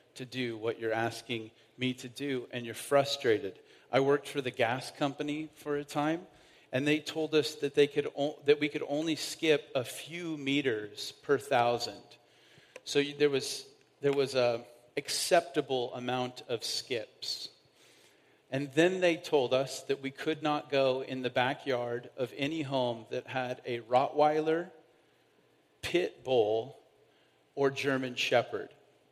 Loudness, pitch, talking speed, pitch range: -32 LUFS, 140 Hz, 150 wpm, 125-150 Hz